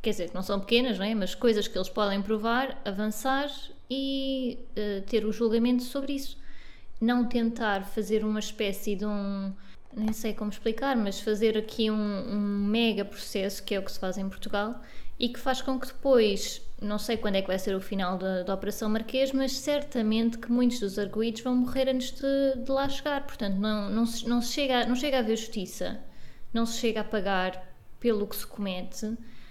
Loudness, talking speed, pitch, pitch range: -29 LUFS, 205 wpm, 220 Hz, 205-245 Hz